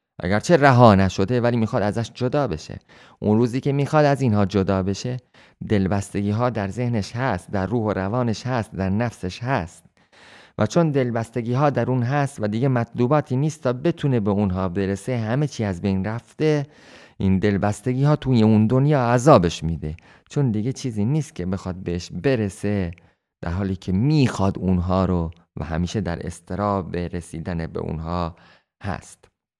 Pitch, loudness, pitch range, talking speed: 105 Hz, -22 LUFS, 95-125 Hz, 160 wpm